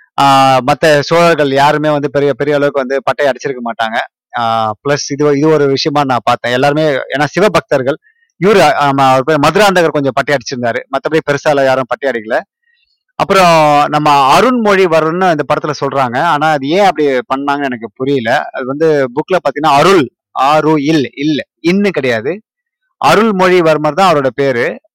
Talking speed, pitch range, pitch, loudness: 110 wpm, 135-160 Hz, 145 Hz, -11 LUFS